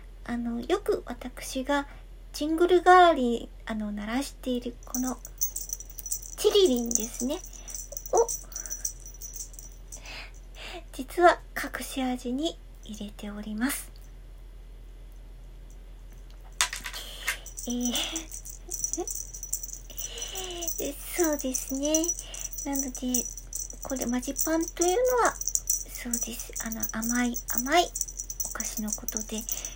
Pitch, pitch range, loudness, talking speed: 265 Hz, 240-335 Hz, -28 LUFS, 170 characters per minute